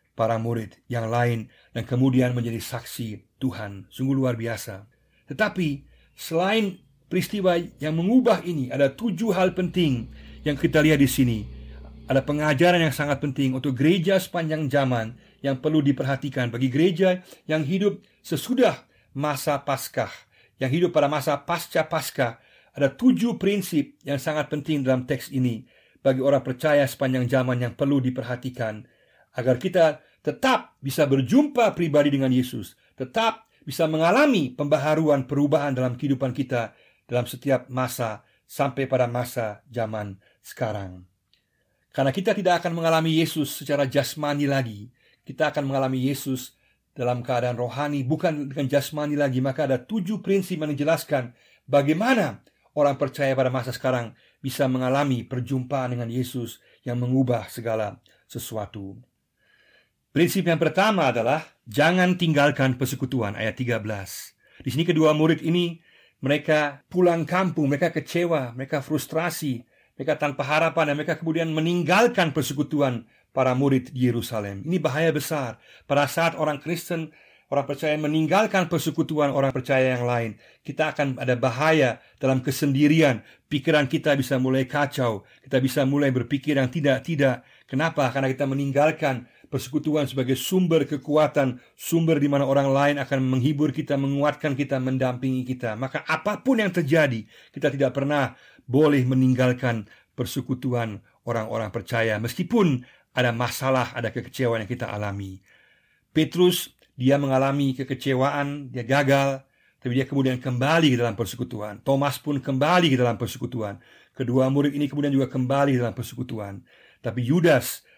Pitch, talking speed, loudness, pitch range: 140 Hz, 135 wpm, -24 LUFS, 125-155 Hz